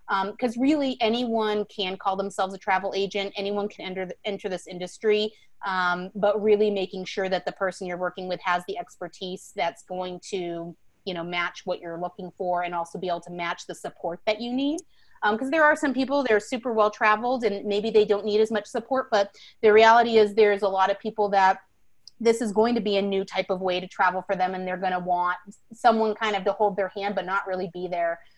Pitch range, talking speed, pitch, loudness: 185-215 Hz, 235 wpm, 195 Hz, -25 LUFS